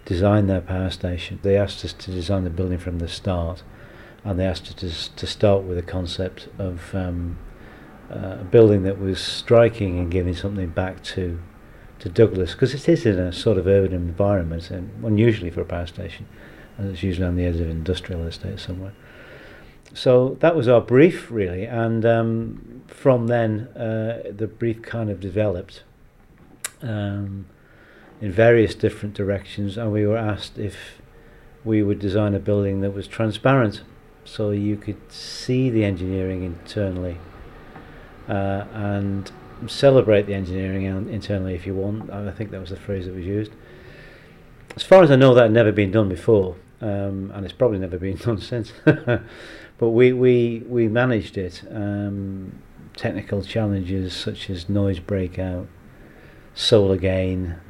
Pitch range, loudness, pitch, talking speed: 95-110 Hz, -21 LUFS, 100 Hz, 165 wpm